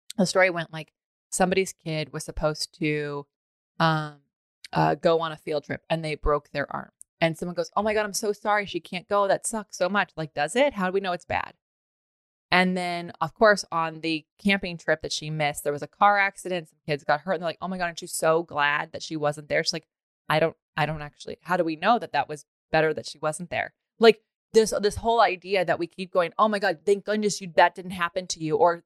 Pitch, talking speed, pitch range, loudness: 170 Hz, 250 wpm, 155-190 Hz, -25 LUFS